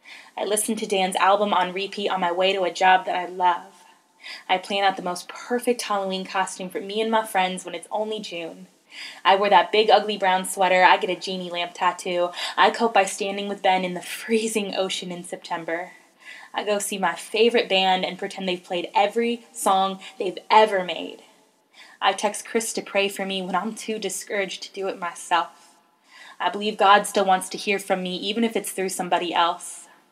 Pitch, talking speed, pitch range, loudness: 190 Hz, 205 wpm, 180-205 Hz, -23 LUFS